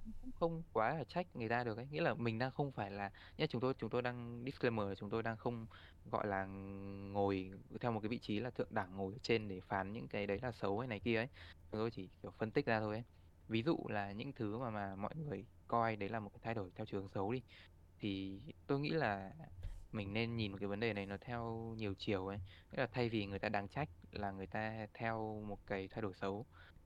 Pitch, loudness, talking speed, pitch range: 105 Hz, -42 LUFS, 255 wpm, 100-120 Hz